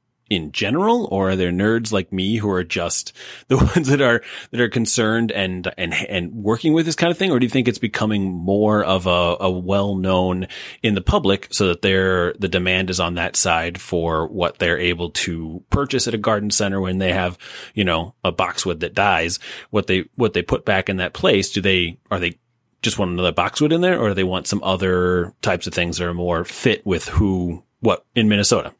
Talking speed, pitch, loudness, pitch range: 225 wpm, 95 Hz, -19 LUFS, 90-110 Hz